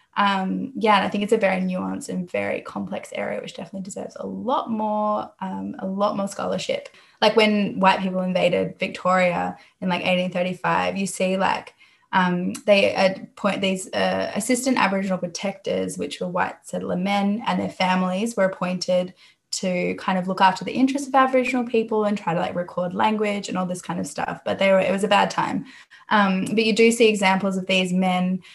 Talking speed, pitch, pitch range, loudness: 195 wpm, 190 Hz, 185-210 Hz, -22 LUFS